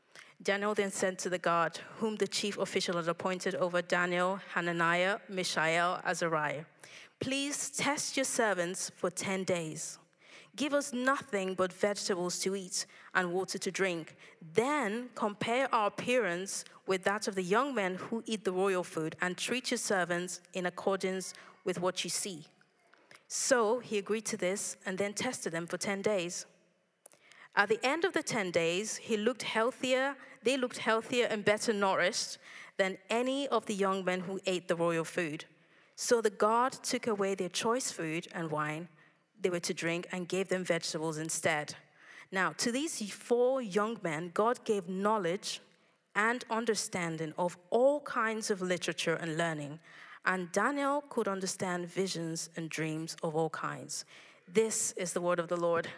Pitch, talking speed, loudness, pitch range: 190 Hz, 165 wpm, -33 LUFS, 175-220 Hz